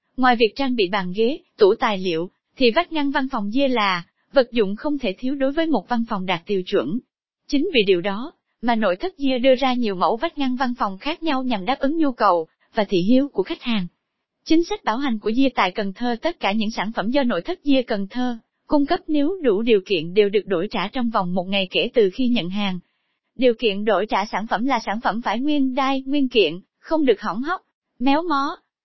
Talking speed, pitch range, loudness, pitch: 245 wpm, 210-280 Hz, -21 LUFS, 245 Hz